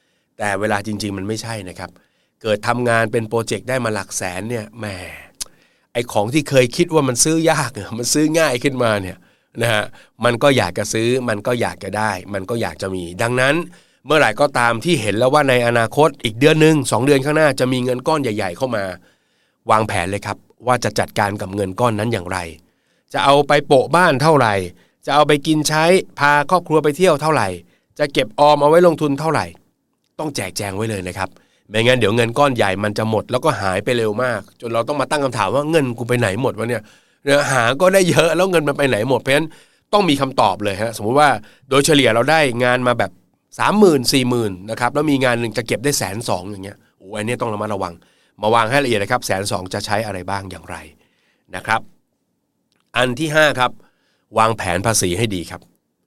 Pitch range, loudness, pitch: 105-145 Hz, -17 LUFS, 120 Hz